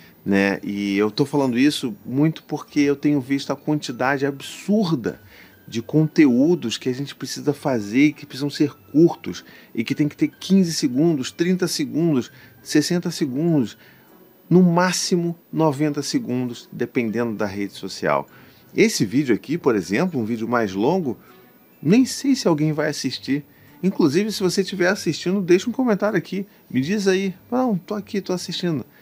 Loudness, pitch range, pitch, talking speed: -21 LUFS, 135-180 Hz, 150 Hz, 160 wpm